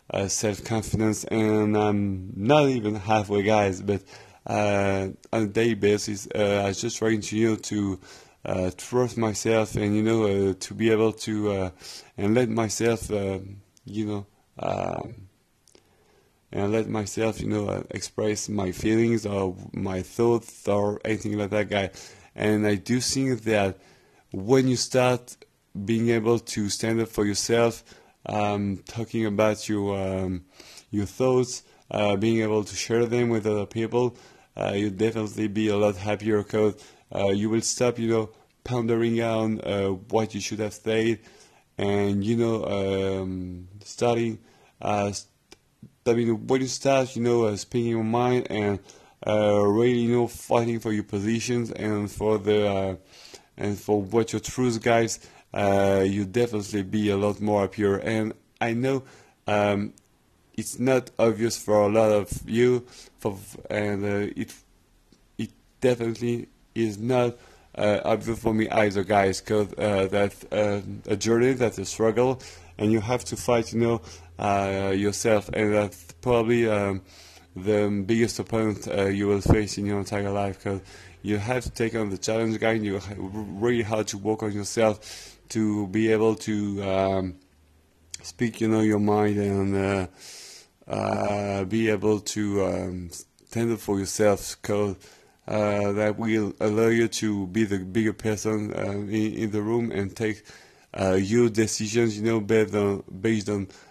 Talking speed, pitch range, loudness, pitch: 165 wpm, 100-115 Hz, -25 LUFS, 105 Hz